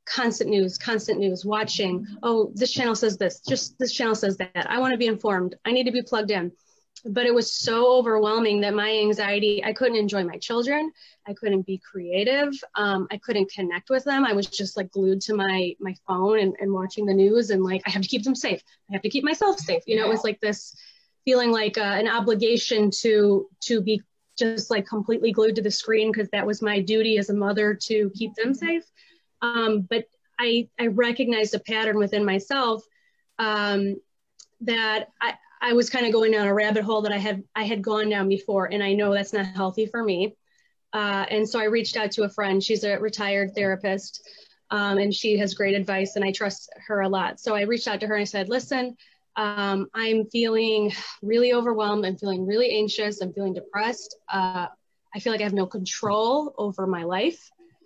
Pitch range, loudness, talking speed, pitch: 200-230 Hz, -24 LUFS, 215 wpm, 215 Hz